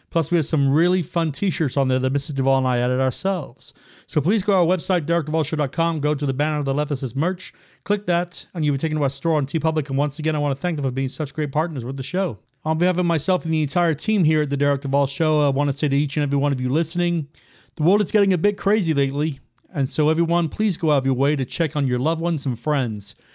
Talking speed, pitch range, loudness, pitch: 285 wpm, 140-170 Hz, -21 LUFS, 155 Hz